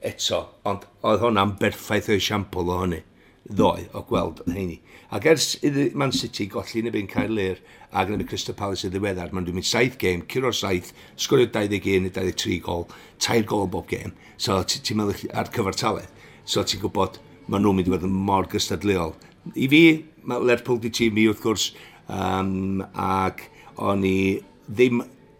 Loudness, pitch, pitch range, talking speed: -23 LUFS, 100 Hz, 95-110 Hz, 185 wpm